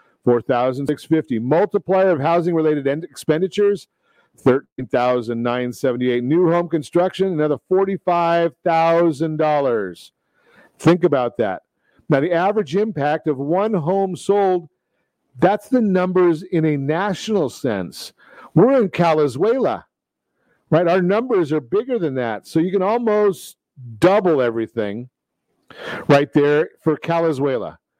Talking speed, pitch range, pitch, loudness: 105 wpm, 145-190 Hz, 165 Hz, -19 LUFS